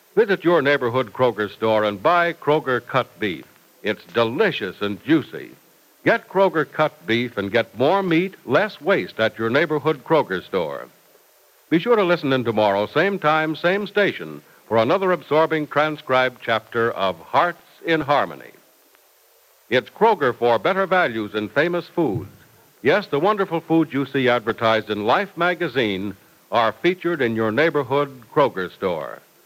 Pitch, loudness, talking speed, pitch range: 145 Hz, -21 LUFS, 150 wpm, 115-170 Hz